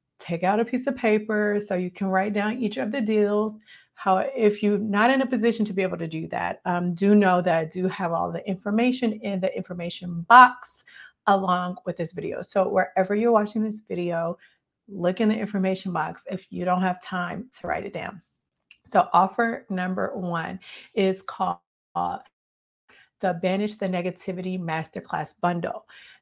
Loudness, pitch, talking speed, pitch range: -24 LUFS, 190 Hz, 180 wpm, 180-210 Hz